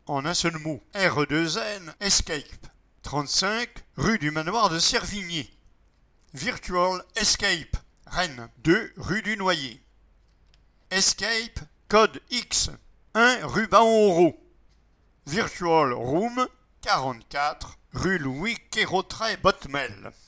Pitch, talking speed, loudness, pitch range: 175 Hz, 95 wpm, -24 LUFS, 145-215 Hz